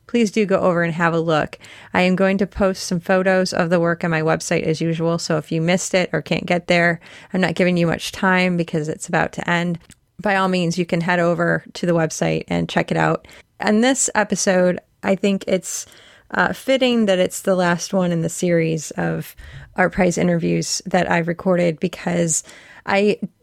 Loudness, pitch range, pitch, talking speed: -19 LUFS, 165-190 Hz, 180 Hz, 210 wpm